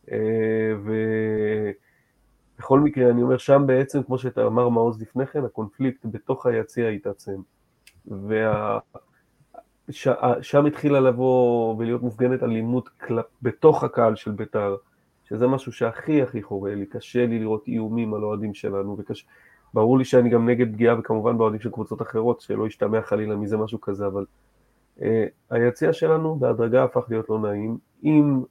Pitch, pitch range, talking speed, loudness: 115 Hz, 110-125 Hz, 145 wpm, -23 LUFS